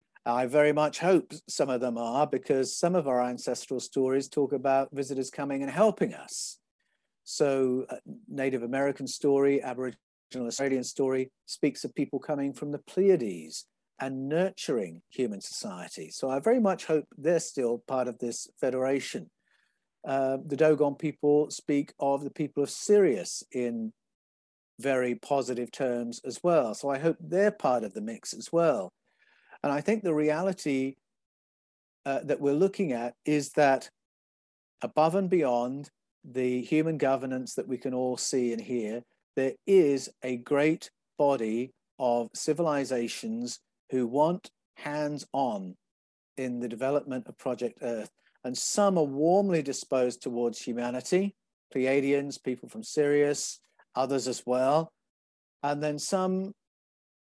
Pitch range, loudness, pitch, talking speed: 125-150 Hz, -29 LUFS, 135 Hz, 140 wpm